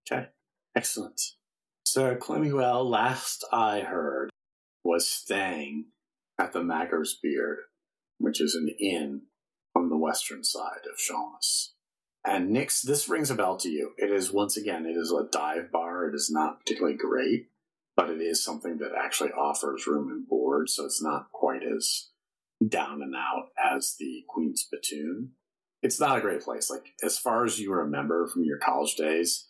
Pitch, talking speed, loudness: 105 Hz, 165 wpm, -28 LUFS